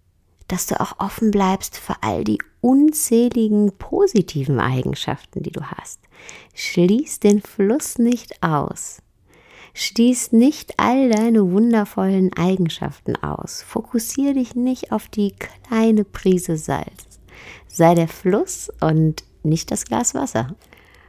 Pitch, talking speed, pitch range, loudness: 205 Hz, 120 wpm, 175-235 Hz, -19 LUFS